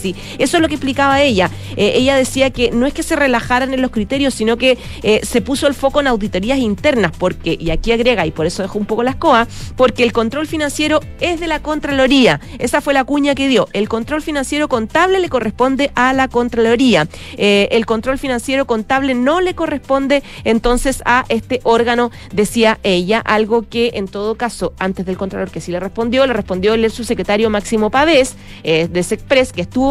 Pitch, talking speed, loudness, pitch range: 245 Hz, 205 wpm, -15 LUFS, 215-270 Hz